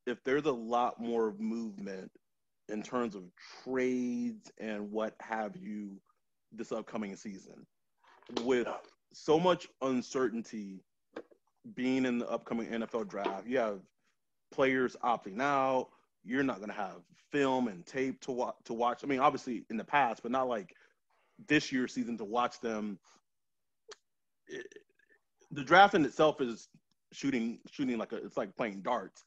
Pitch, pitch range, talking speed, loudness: 125 Hz, 115-145 Hz, 150 wpm, -33 LUFS